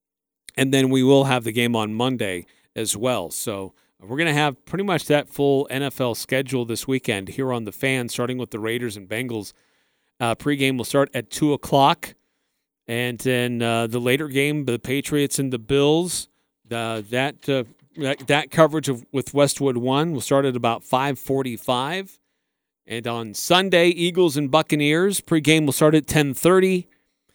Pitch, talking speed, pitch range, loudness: 135 Hz, 175 wpm, 120-145 Hz, -21 LUFS